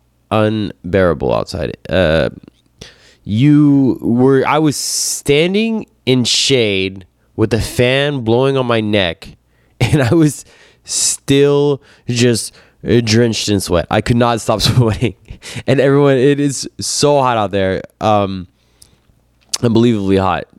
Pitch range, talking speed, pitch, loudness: 105-140 Hz, 120 wpm, 120 Hz, -14 LUFS